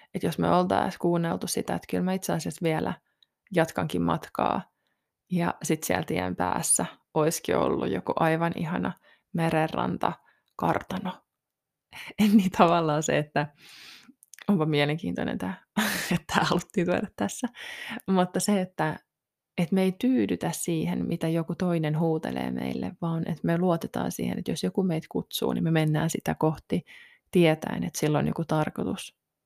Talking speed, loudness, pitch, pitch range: 145 wpm, -27 LUFS, 165 Hz, 155-185 Hz